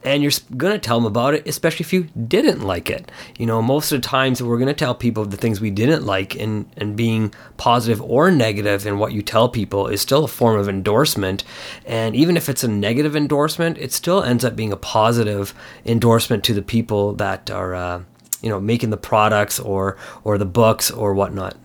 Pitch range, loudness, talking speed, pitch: 105-130 Hz, -19 LUFS, 215 wpm, 115 Hz